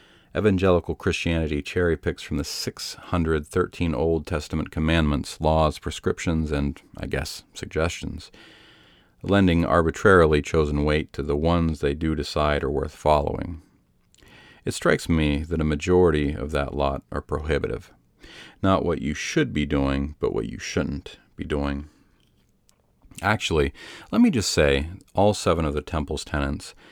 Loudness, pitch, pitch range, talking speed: -24 LUFS, 80 Hz, 75-85 Hz, 140 wpm